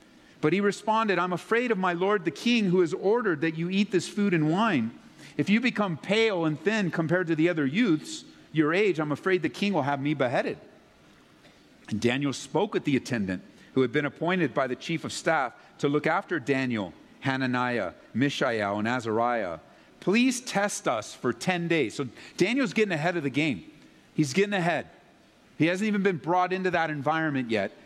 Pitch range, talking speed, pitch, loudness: 145-200 Hz, 190 wpm, 170 Hz, -27 LUFS